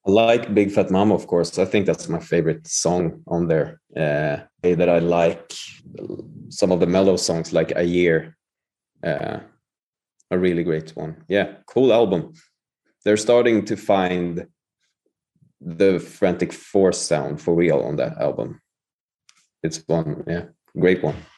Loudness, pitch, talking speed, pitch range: -21 LUFS, 85 Hz, 150 wpm, 85-95 Hz